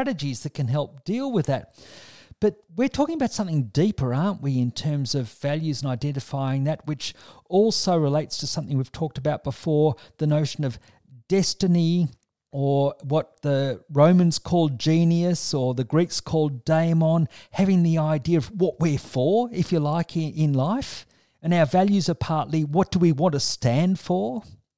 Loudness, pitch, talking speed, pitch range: -23 LUFS, 155 Hz, 165 wpm, 140-175 Hz